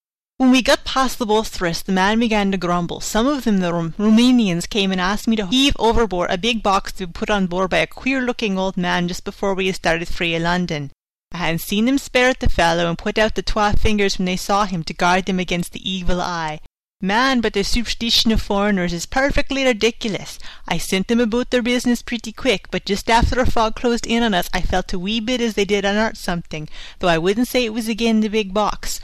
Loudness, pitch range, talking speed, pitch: -19 LUFS, 180-235 Hz, 235 wpm, 205 Hz